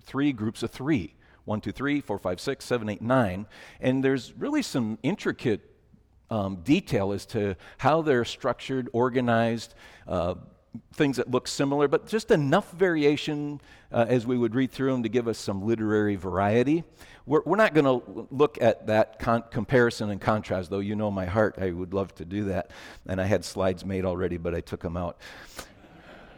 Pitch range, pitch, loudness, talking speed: 100-135 Hz, 115 Hz, -27 LUFS, 185 wpm